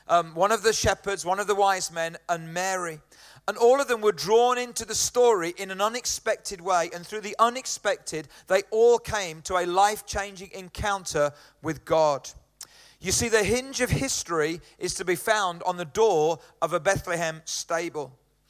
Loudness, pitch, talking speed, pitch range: -25 LUFS, 190 Hz, 180 wpm, 165-215 Hz